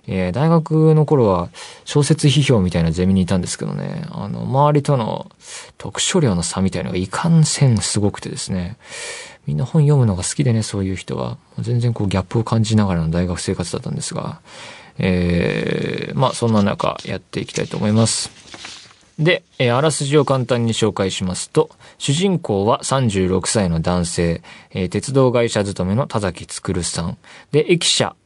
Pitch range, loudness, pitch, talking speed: 95-140 Hz, -18 LUFS, 110 Hz, 335 characters per minute